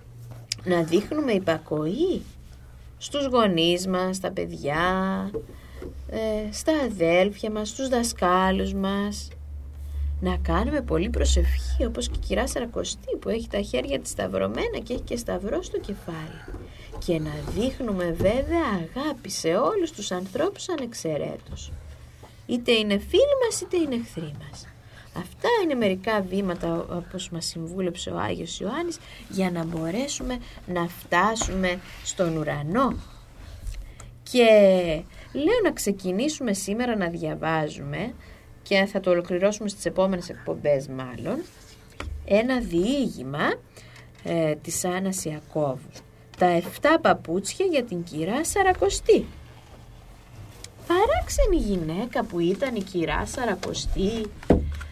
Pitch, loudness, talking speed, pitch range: 185 Hz, -25 LUFS, 115 wpm, 155-235 Hz